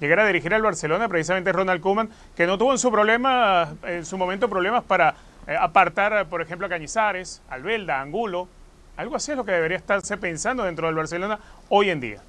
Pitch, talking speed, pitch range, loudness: 190 Hz, 195 wpm, 175-220 Hz, -22 LUFS